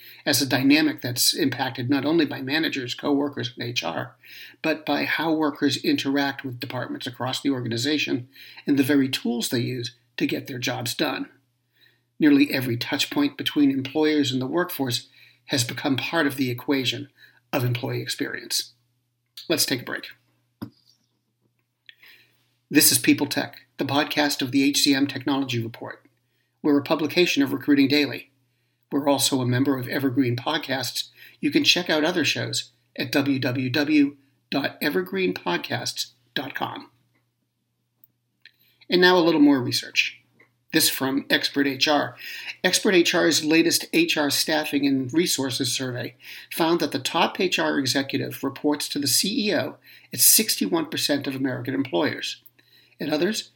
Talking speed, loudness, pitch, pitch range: 140 wpm, -23 LUFS, 140 Hz, 125-150 Hz